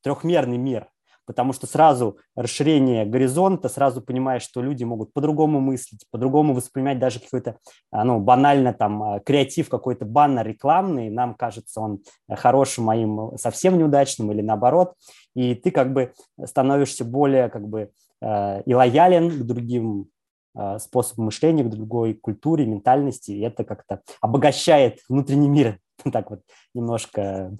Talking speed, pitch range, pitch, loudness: 135 wpm, 110-140 Hz, 125 Hz, -21 LUFS